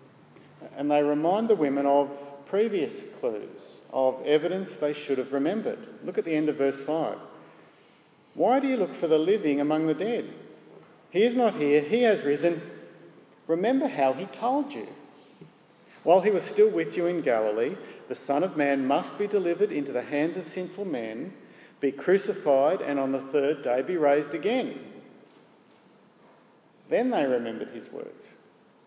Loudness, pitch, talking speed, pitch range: -26 LUFS, 155 Hz, 165 wpm, 140-205 Hz